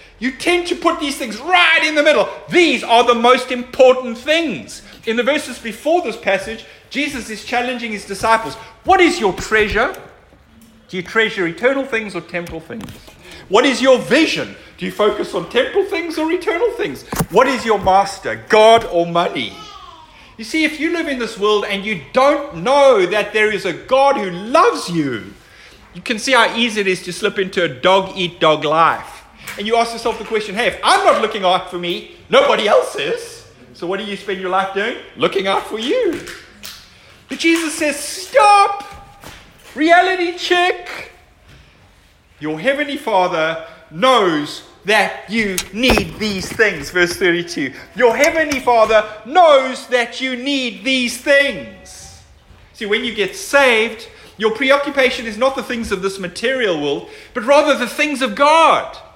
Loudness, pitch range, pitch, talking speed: -16 LUFS, 200-295 Hz, 240 Hz, 170 wpm